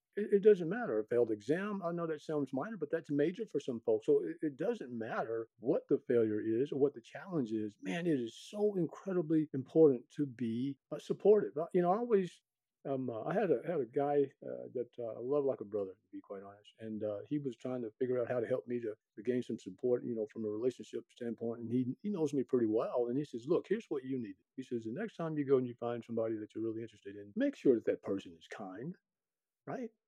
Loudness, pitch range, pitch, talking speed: -36 LUFS, 115-170 Hz, 130 Hz, 250 wpm